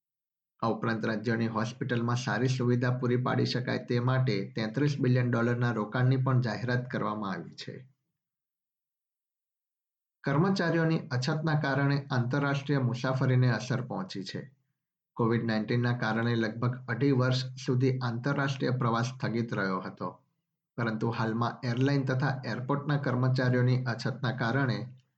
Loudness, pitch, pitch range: -30 LUFS, 125 Hz, 120-140 Hz